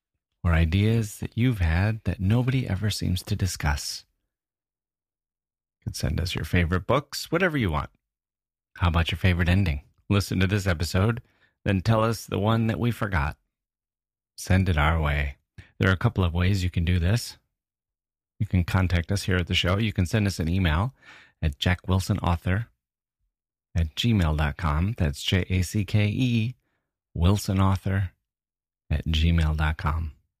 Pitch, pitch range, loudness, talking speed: 95 Hz, 85-105 Hz, -25 LUFS, 155 wpm